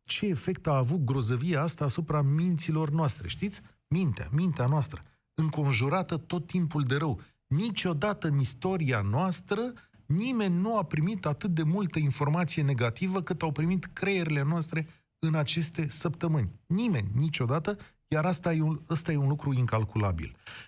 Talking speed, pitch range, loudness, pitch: 145 wpm, 140-175 Hz, -29 LUFS, 155 Hz